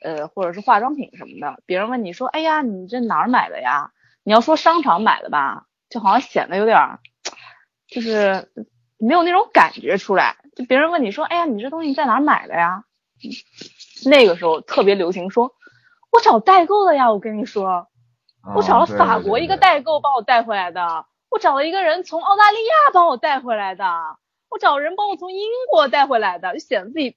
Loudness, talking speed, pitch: -17 LUFS, 300 characters per minute, 270 Hz